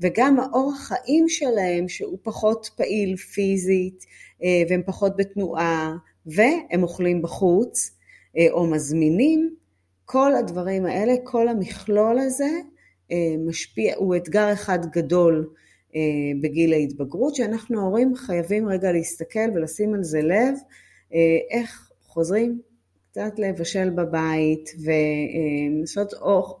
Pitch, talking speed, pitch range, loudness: 185 Hz, 100 wpm, 165-220 Hz, -22 LUFS